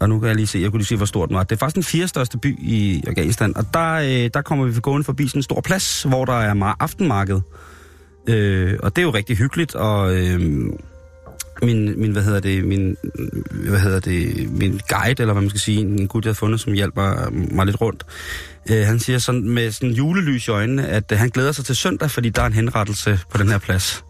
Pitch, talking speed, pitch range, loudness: 110 Hz, 245 wpm, 100-125 Hz, -19 LUFS